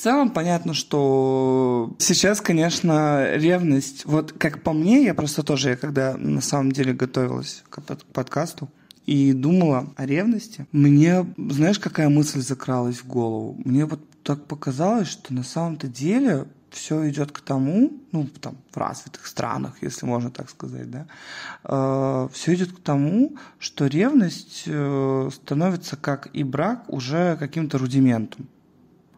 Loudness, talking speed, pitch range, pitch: -22 LUFS, 140 wpm, 135-170 Hz, 145 Hz